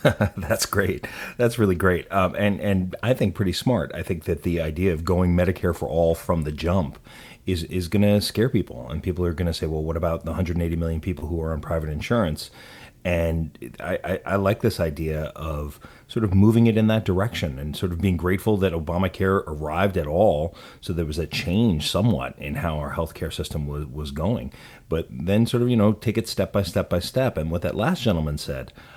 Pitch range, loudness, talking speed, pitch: 80-100 Hz, -24 LUFS, 220 wpm, 90 Hz